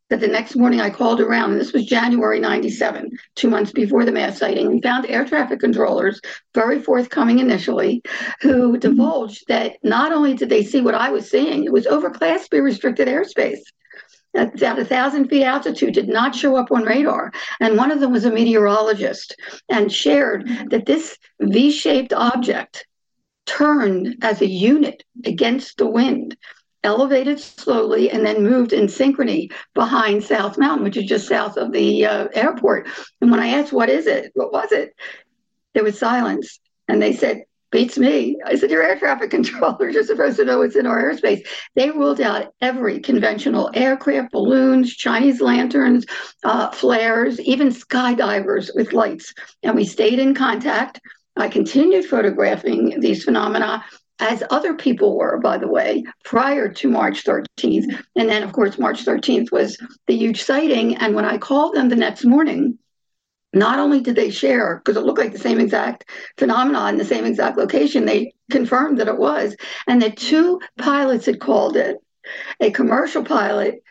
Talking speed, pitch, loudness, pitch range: 175 wpm, 250 Hz, -18 LUFS, 225-280 Hz